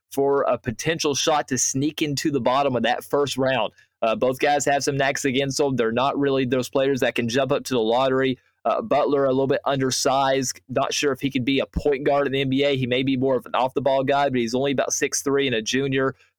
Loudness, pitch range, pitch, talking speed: -22 LUFS, 130-140 Hz, 135 Hz, 255 wpm